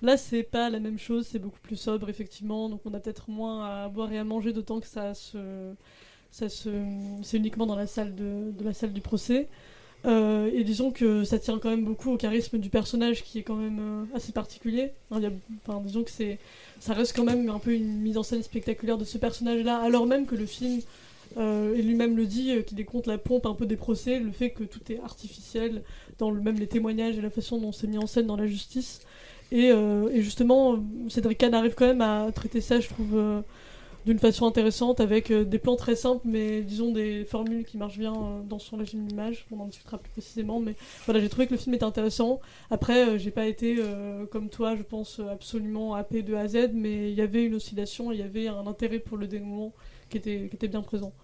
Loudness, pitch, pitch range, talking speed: -28 LUFS, 220 Hz, 215-230 Hz, 240 wpm